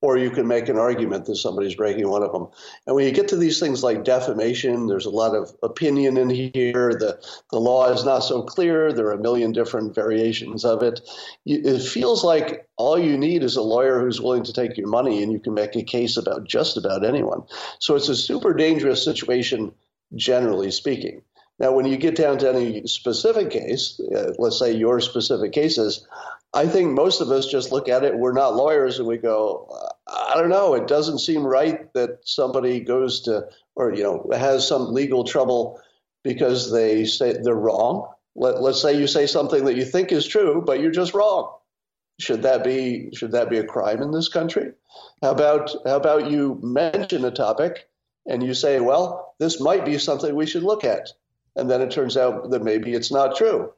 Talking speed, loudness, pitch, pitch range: 205 wpm, -21 LUFS, 130 Hz, 120-150 Hz